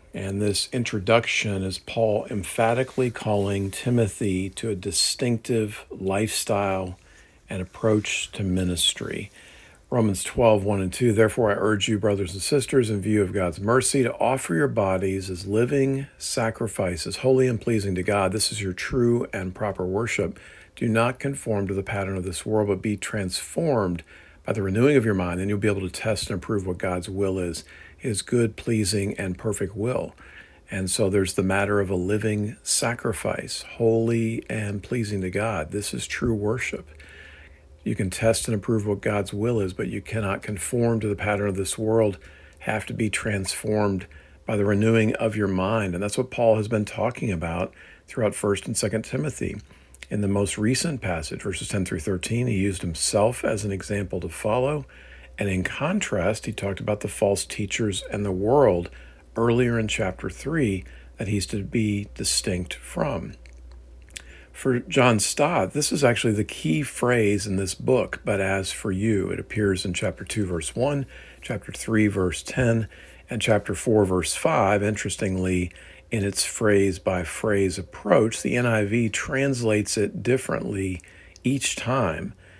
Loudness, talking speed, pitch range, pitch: -24 LUFS, 170 wpm, 95-115 Hz, 105 Hz